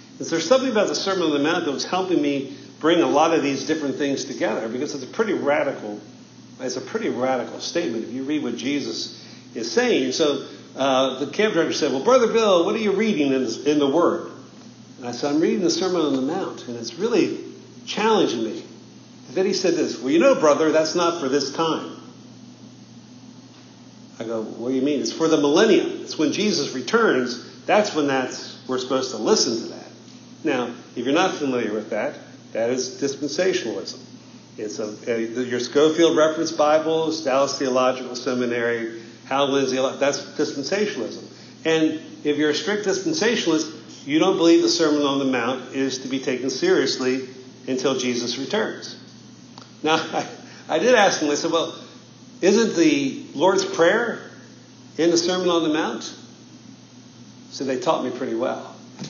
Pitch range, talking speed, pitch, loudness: 130-170 Hz, 180 wpm, 145 Hz, -22 LUFS